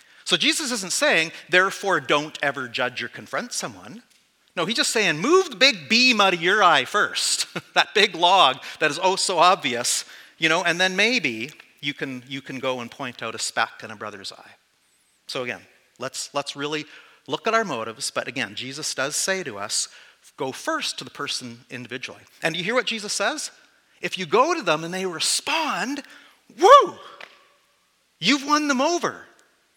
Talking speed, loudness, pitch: 185 wpm, -21 LUFS, 170 Hz